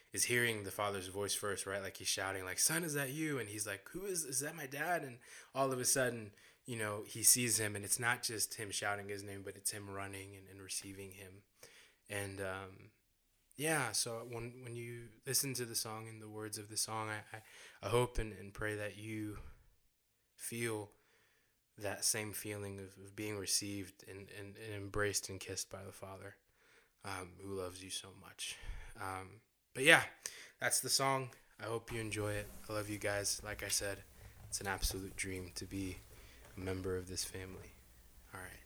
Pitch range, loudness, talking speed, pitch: 95-115 Hz, -38 LUFS, 205 wpm, 105 Hz